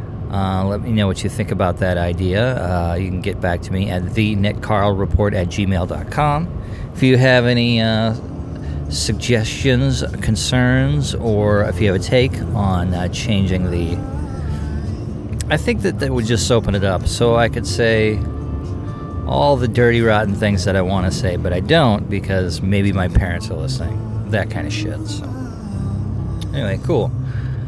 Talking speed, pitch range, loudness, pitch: 175 wpm, 95-115 Hz, -18 LUFS, 105 Hz